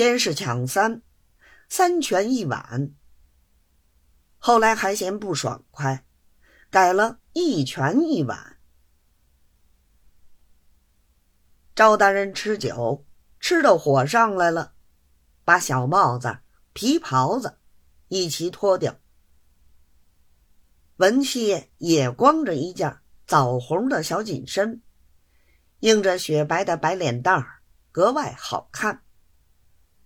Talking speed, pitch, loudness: 135 characters per minute, 130 Hz, -22 LUFS